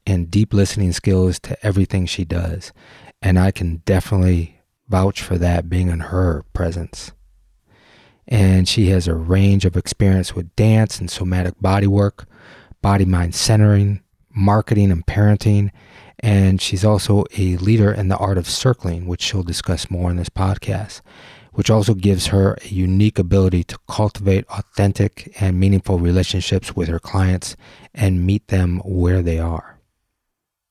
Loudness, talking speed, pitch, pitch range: -18 LUFS, 150 wpm, 95 Hz, 90-105 Hz